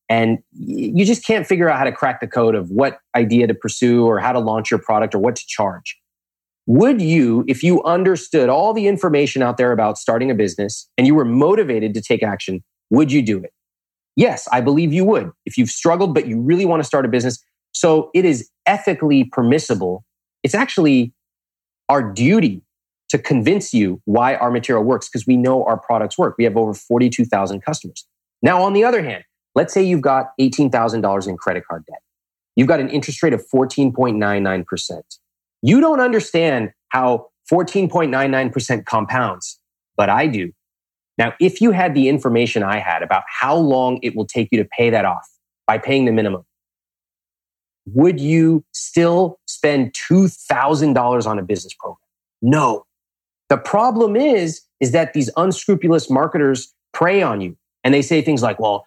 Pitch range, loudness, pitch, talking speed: 105-160 Hz, -17 LUFS, 125 Hz, 175 wpm